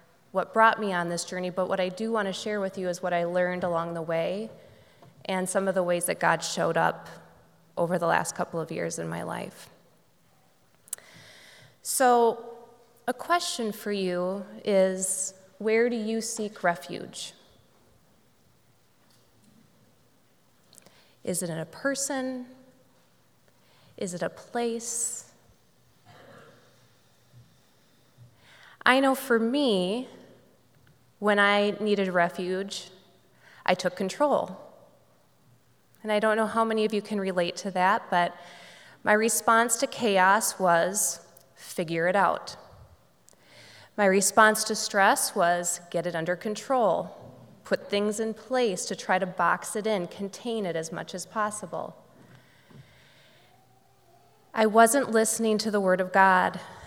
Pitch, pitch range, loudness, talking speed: 195 Hz, 180-225 Hz, -26 LUFS, 130 wpm